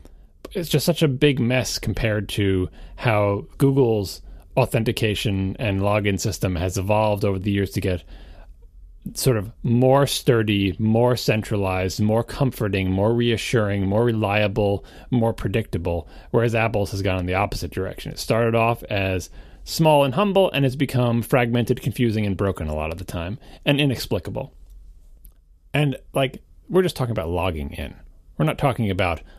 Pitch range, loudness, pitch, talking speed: 95-125 Hz, -22 LUFS, 105 Hz, 155 wpm